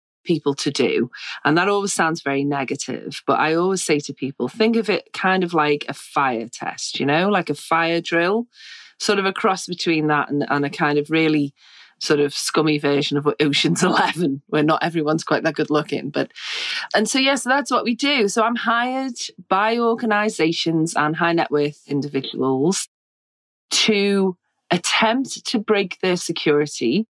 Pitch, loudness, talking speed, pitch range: 165 Hz, -20 LUFS, 185 wpm, 145-205 Hz